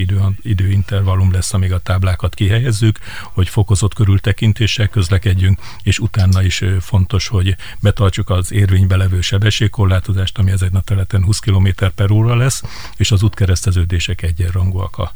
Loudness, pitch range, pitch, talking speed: -15 LUFS, 95-105 Hz, 100 Hz, 140 wpm